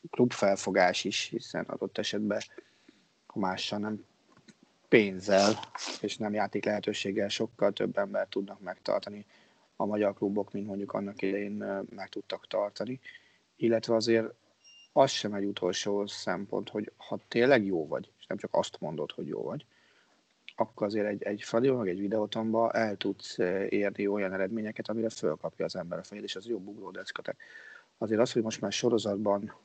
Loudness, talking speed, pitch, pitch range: -31 LUFS, 155 wpm, 105 Hz, 100-110 Hz